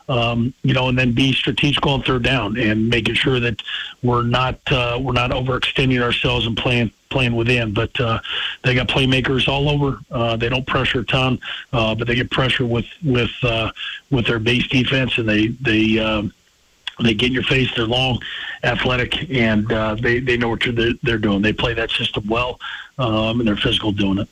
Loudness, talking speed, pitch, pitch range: -18 LUFS, 200 wpm, 120 Hz, 115-130 Hz